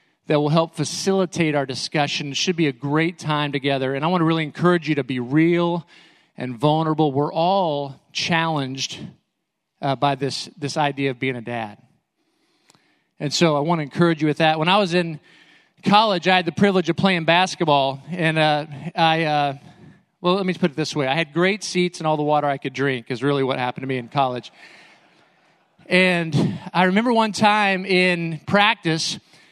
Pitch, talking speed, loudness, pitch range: 160 Hz, 190 wpm, -20 LUFS, 145-180 Hz